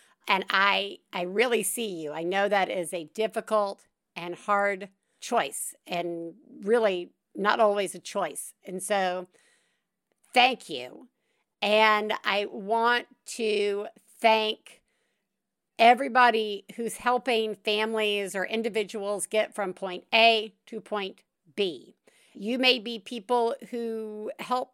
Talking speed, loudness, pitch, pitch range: 120 wpm, -26 LUFS, 215 Hz, 195-230 Hz